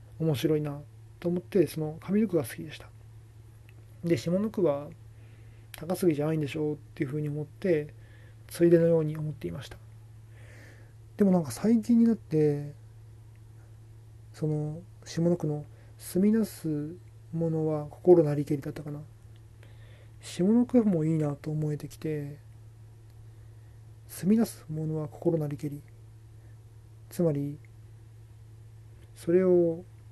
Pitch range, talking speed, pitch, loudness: 110-160 Hz, 250 characters per minute, 140 Hz, -28 LUFS